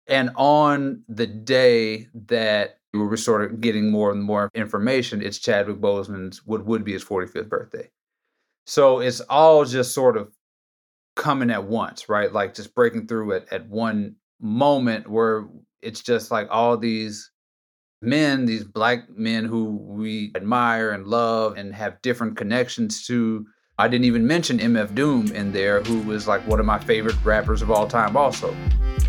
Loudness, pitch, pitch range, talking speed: -21 LUFS, 115 Hz, 105-125 Hz, 170 wpm